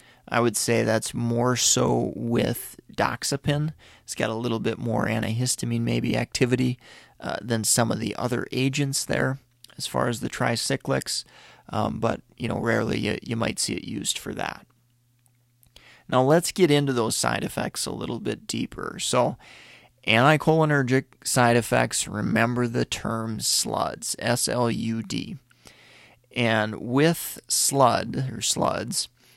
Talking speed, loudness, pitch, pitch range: 140 wpm, -24 LUFS, 120 Hz, 115-130 Hz